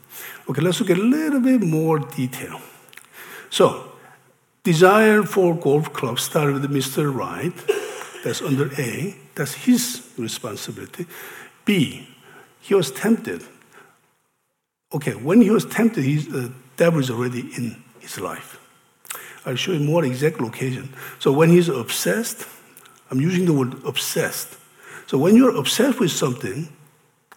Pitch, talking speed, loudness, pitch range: 160 Hz, 150 wpm, -20 LUFS, 135-200 Hz